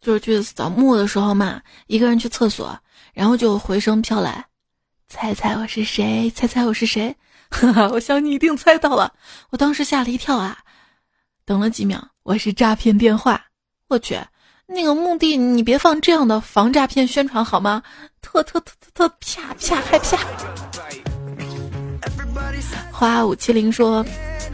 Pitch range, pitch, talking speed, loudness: 215-280 Hz, 230 Hz, 225 characters per minute, -18 LUFS